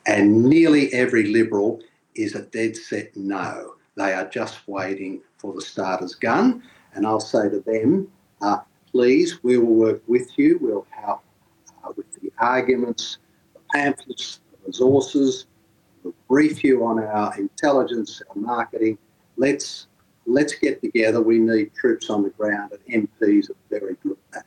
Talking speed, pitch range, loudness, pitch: 160 wpm, 110-165 Hz, -21 LUFS, 115 Hz